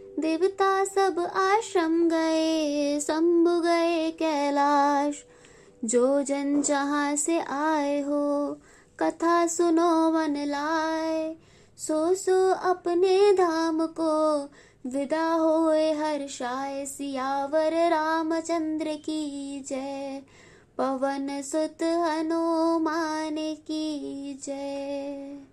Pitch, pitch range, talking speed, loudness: 315 Hz, 285-330 Hz, 80 wpm, -26 LUFS